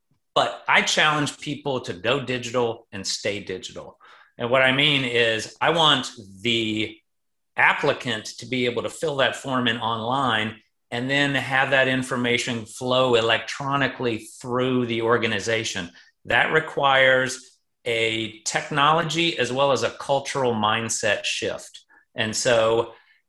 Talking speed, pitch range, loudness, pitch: 130 wpm, 115-135 Hz, -22 LUFS, 120 Hz